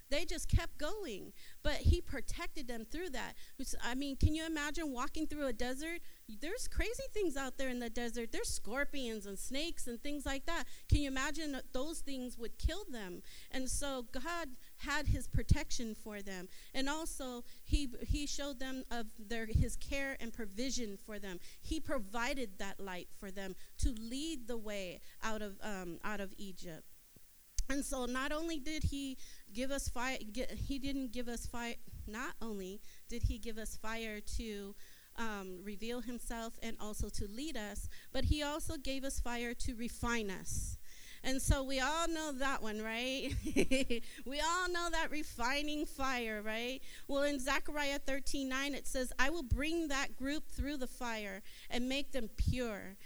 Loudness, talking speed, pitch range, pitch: -40 LUFS, 180 wpm, 225-285 Hz, 260 Hz